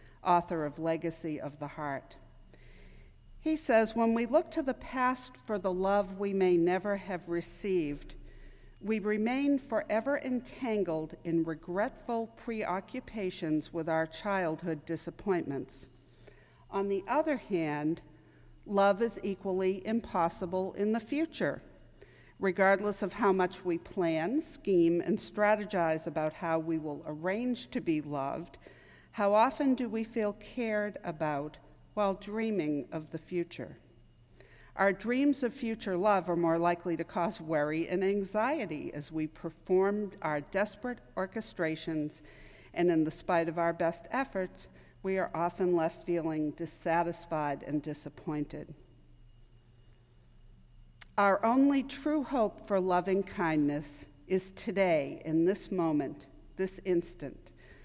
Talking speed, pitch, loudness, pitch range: 125 wpm, 180 Hz, -32 LUFS, 160-210 Hz